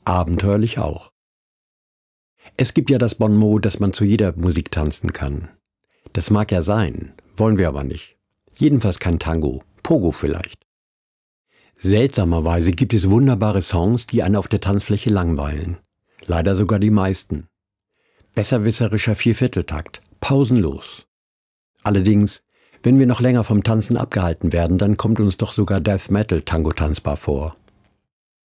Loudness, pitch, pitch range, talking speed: -19 LUFS, 100 Hz, 85-110 Hz, 135 wpm